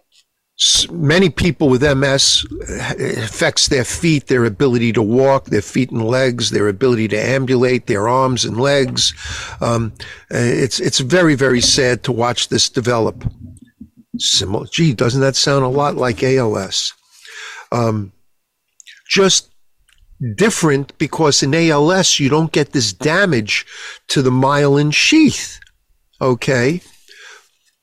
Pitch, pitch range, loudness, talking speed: 135 Hz, 120-155 Hz, -15 LUFS, 125 wpm